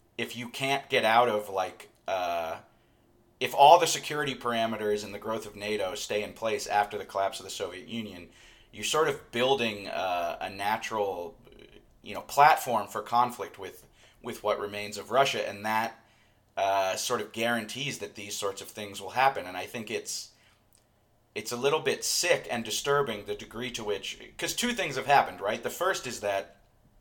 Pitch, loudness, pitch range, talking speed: 110 Hz, -29 LUFS, 105-125 Hz, 185 wpm